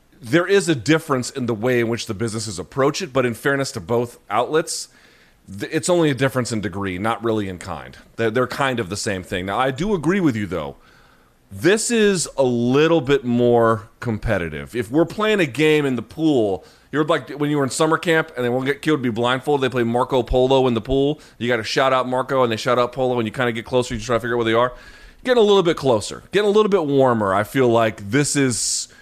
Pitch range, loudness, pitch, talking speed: 115-150 Hz, -20 LUFS, 125 Hz, 250 wpm